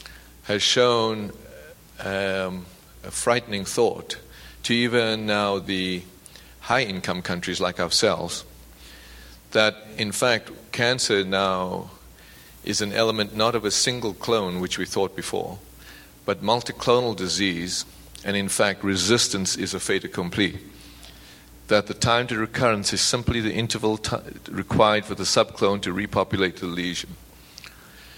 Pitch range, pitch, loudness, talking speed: 90-110 Hz, 100 Hz, -23 LUFS, 130 wpm